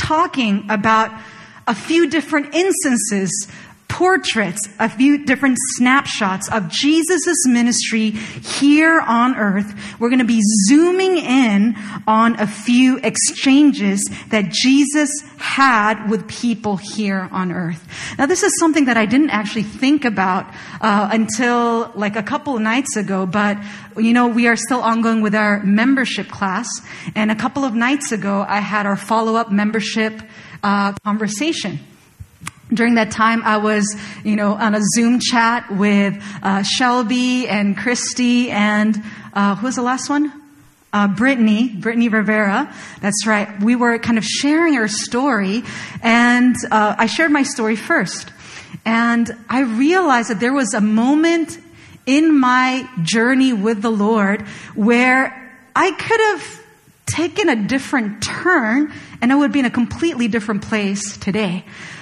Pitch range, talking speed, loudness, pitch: 210-260 Hz, 150 wpm, -16 LUFS, 230 Hz